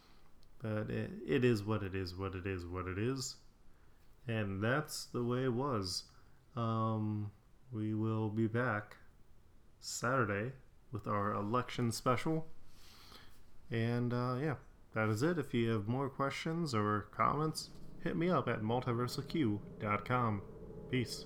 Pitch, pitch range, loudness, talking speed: 115 Hz, 105-130 Hz, -37 LUFS, 135 wpm